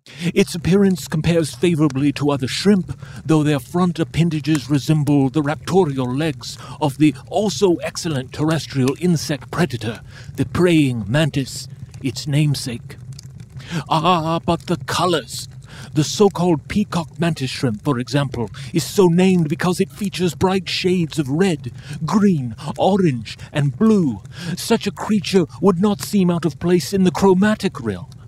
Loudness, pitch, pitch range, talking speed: -19 LUFS, 155 Hz, 135-180 Hz, 140 wpm